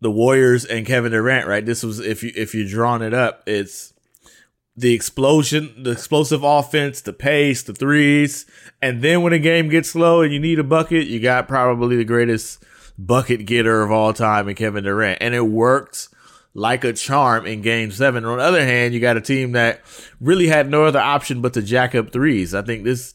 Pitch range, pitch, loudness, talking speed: 115-145 Hz, 125 Hz, -17 LUFS, 215 wpm